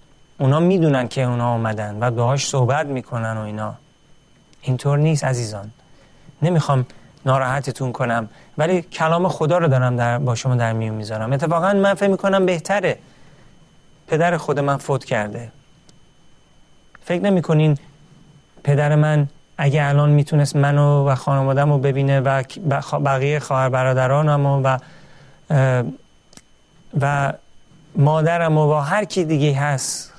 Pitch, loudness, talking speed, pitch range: 145 Hz, -19 LUFS, 125 wpm, 130-155 Hz